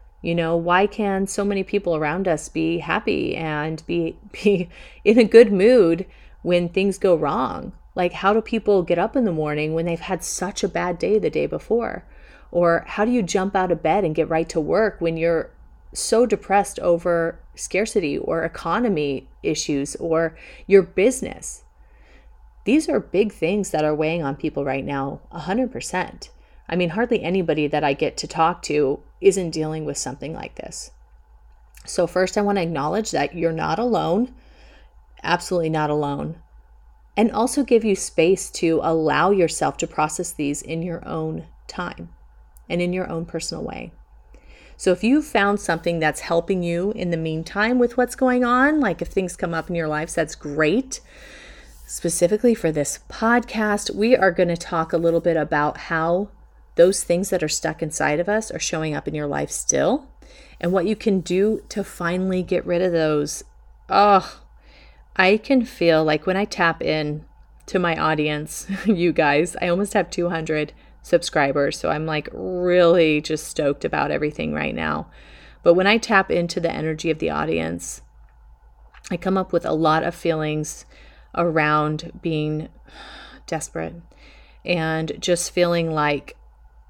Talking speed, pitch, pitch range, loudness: 170 wpm, 170 Hz, 155-195 Hz, -21 LUFS